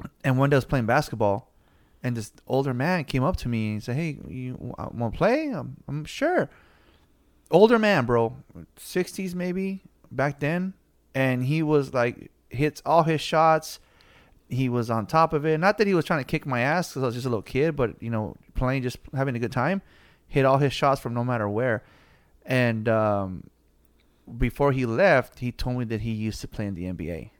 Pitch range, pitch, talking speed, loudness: 115-155 Hz, 130 Hz, 210 wpm, -25 LUFS